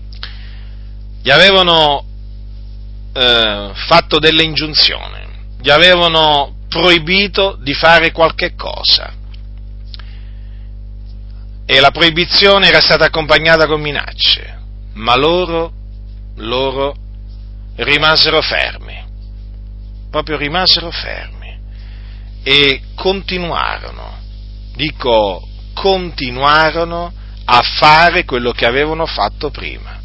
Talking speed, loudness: 80 wpm, -11 LUFS